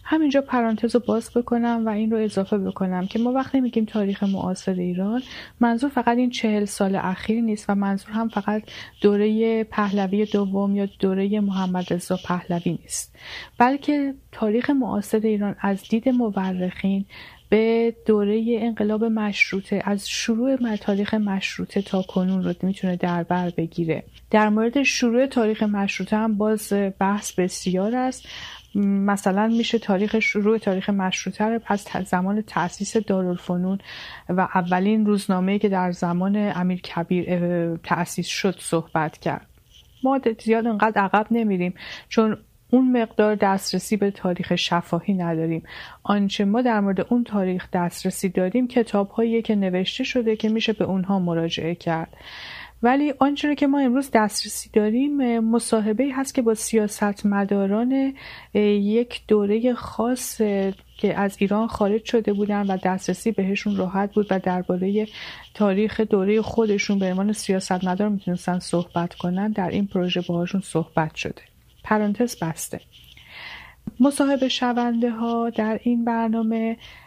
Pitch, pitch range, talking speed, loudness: 205 Hz, 190-225 Hz, 135 wpm, -22 LUFS